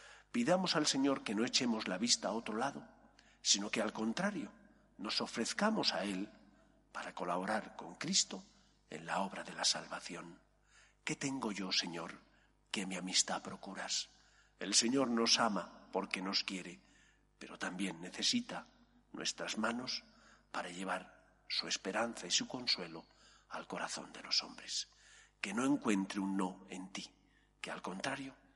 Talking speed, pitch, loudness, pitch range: 150 wpm, 115 Hz, -37 LUFS, 95-140 Hz